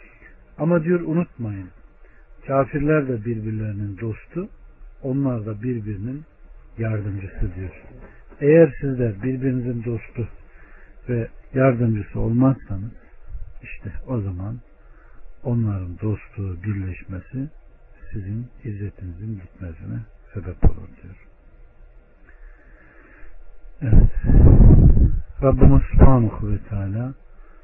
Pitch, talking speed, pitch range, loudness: 110 Hz, 75 wpm, 95-130 Hz, -21 LUFS